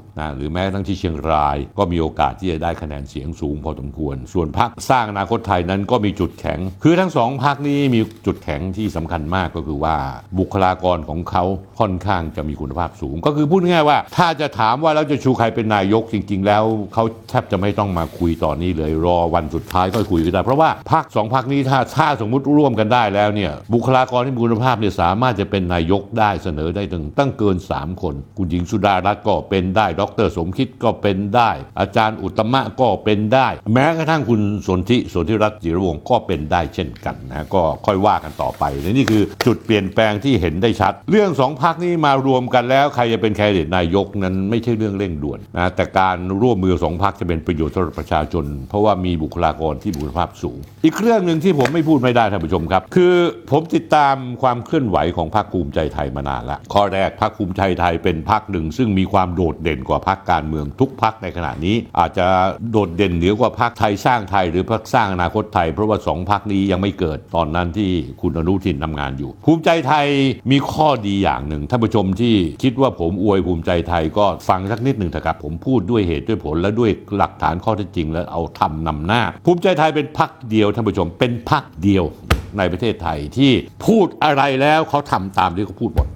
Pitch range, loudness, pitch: 85-120 Hz, -18 LUFS, 100 Hz